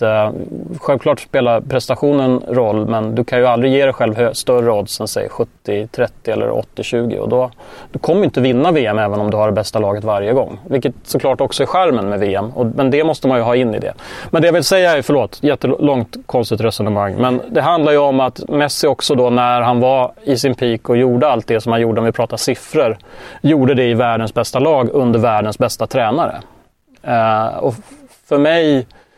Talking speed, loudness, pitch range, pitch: 210 wpm, -15 LUFS, 115-140 Hz, 125 Hz